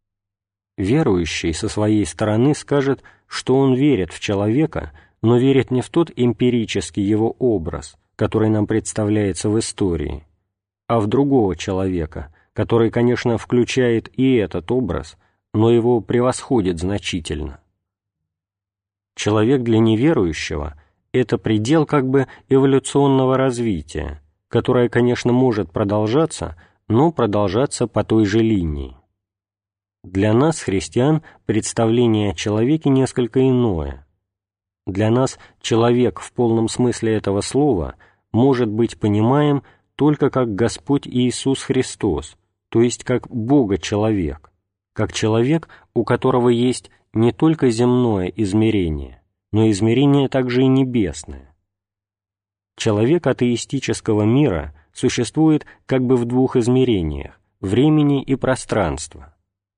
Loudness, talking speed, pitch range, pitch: -18 LUFS, 110 wpm, 95-125 Hz, 110 Hz